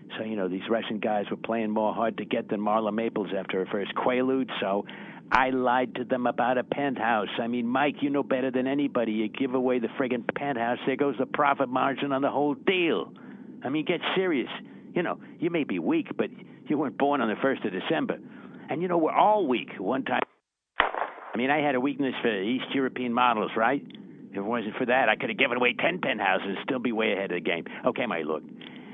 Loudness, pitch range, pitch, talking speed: -27 LUFS, 115-140 Hz, 125 Hz, 230 wpm